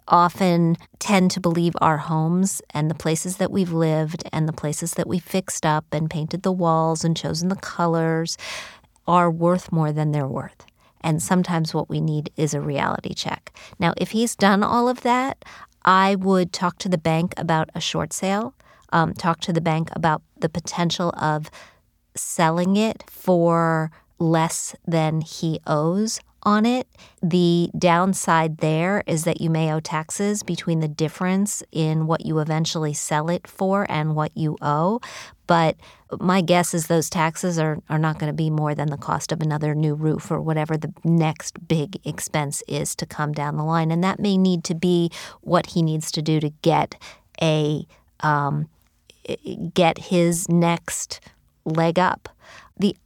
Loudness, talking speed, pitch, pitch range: -22 LUFS, 175 wpm, 165 Hz, 155-180 Hz